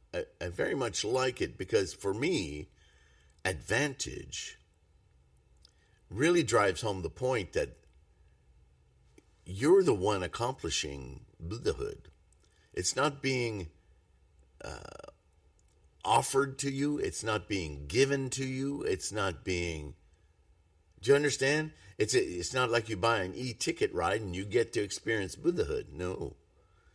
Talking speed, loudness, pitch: 125 wpm, -32 LUFS, 95 Hz